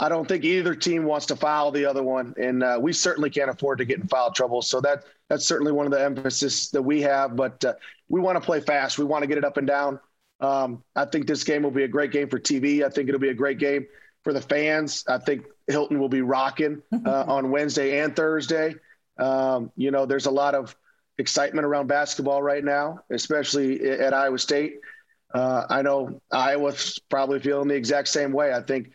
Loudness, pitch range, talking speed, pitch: -24 LUFS, 135-150 Hz, 230 wpm, 140 Hz